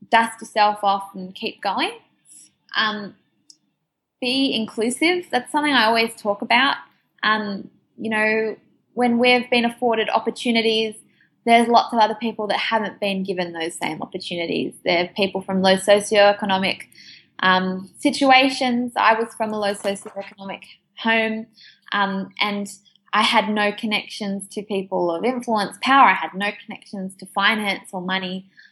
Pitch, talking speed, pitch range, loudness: 215 Hz, 145 wpm, 195-230 Hz, -20 LUFS